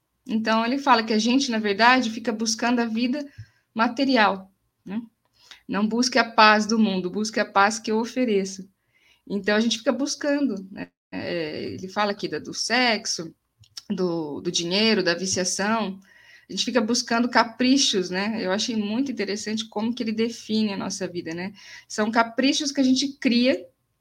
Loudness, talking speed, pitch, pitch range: -23 LUFS, 170 wpm, 220 Hz, 195-240 Hz